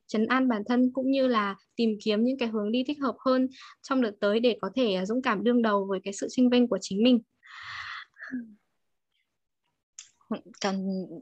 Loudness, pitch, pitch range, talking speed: -27 LUFS, 235 Hz, 205-255 Hz, 185 wpm